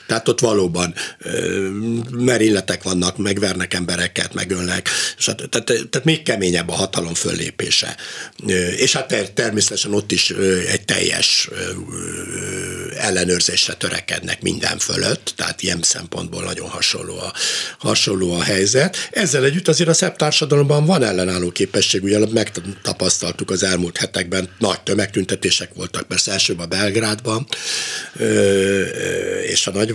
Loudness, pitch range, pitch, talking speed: -18 LUFS, 90-115 Hz, 95 Hz, 115 wpm